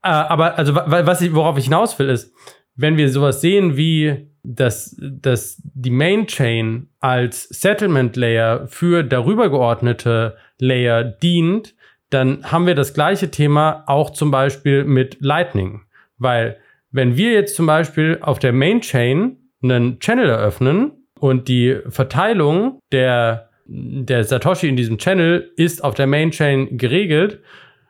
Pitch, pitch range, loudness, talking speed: 140 Hz, 125-170 Hz, -17 LUFS, 140 wpm